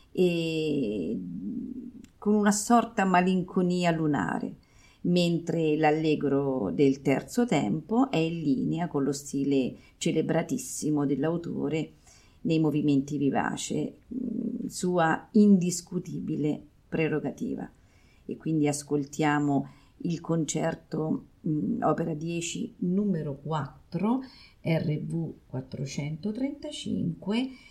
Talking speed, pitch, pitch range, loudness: 80 wpm, 165 Hz, 150-200 Hz, -28 LUFS